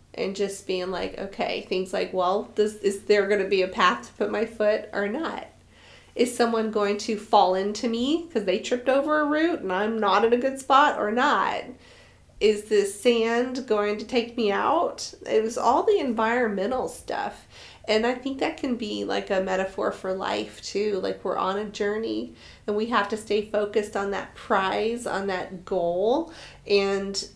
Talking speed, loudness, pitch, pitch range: 195 wpm, -25 LUFS, 210 Hz, 195-240 Hz